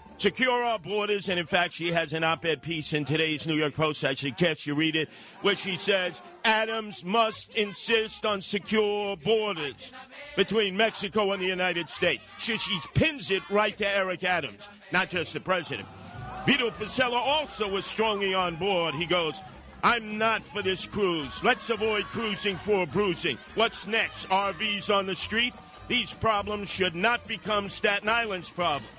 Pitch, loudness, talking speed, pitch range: 200 Hz, -27 LUFS, 170 wpm, 175-220 Hz